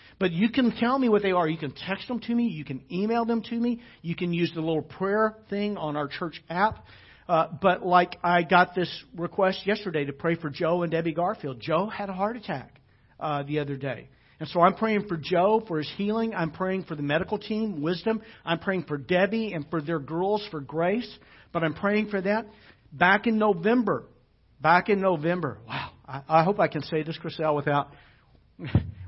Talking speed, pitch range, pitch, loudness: 210 wpm, 150-205 Hz, 175 Hz, -26 LUFS